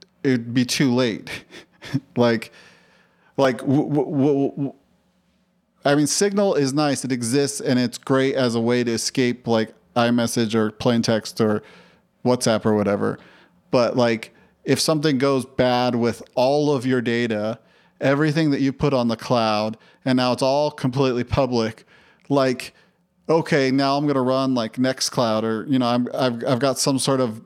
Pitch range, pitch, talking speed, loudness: 120-140 Hz, 130 Hz, 170 wpm, -21 LUFS